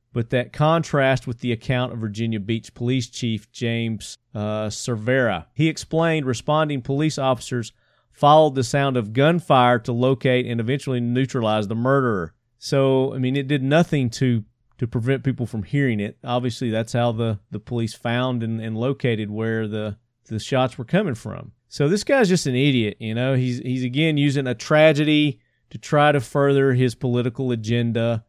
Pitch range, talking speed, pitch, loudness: 115-140 Hz, 175 wpm, 125 Hz, -21 LUFS